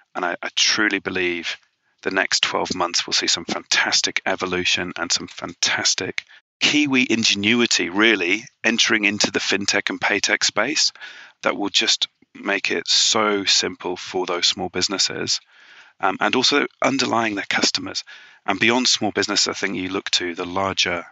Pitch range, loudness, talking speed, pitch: 90-120 Hz, -19 LUFS, 160 wpm, 100 Hz